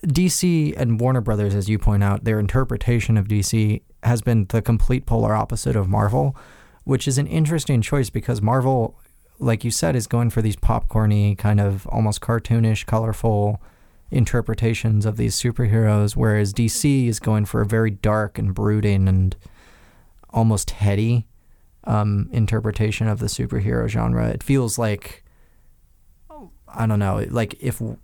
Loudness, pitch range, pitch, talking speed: -21 LUFS, 105-120 Hz, 110 Hz, 150 wpm